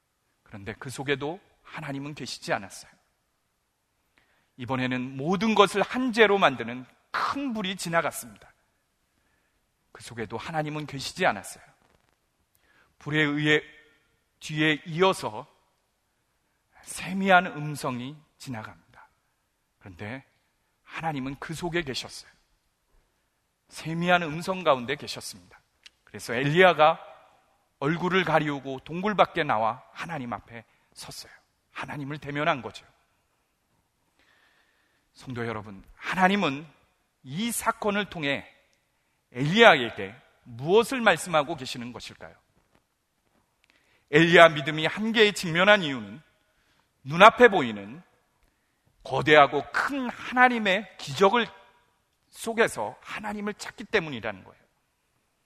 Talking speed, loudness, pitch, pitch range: 240 characters per minute, -24 LUFS, 155 Hz, 135-190 Hz